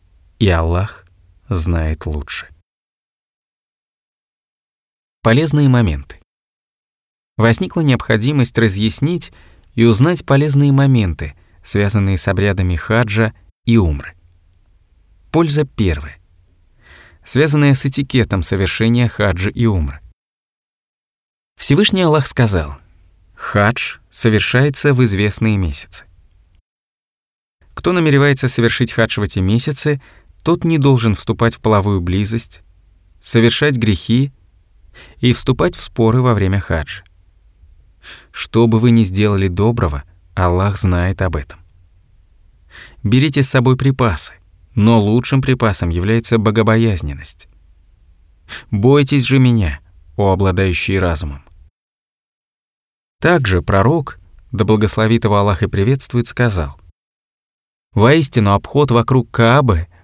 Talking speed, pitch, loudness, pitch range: 95 wpm, 105 Hz, -14 LUFS, 90-120 Hz